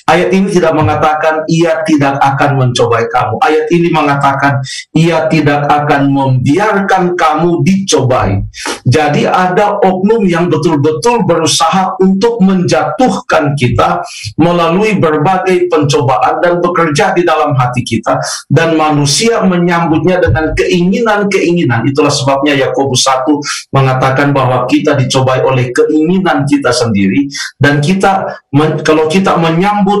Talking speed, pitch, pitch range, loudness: 115 wpm, 155 Hz, 140-175 Hz, -10 LUFS